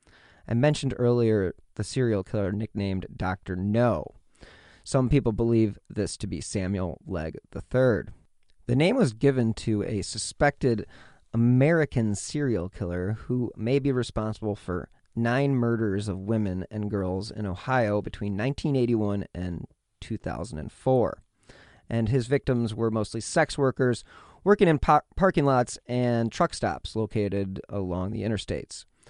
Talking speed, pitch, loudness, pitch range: 130 wpm, 110 Hz, -27 LUFS, 100-125 Hz